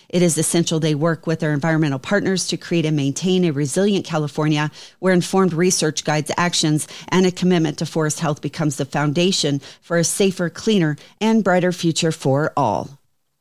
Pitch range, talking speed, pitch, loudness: 150-180 Hz, 175 wpm, 165 Hz, -19 LUFS